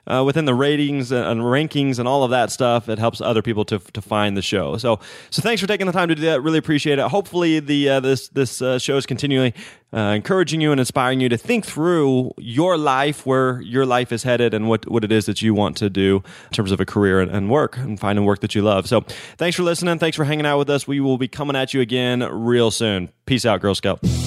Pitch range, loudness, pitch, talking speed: 110-145 Hz, -19 LUFS, 125 Hz, 260 wpm